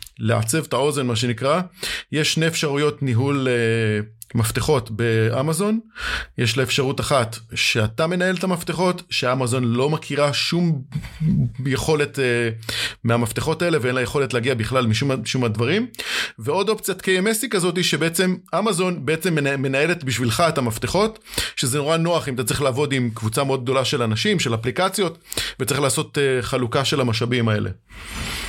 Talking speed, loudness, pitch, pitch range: 150 wpm, -21 LUFS, 140 Hz, 120-165 Hz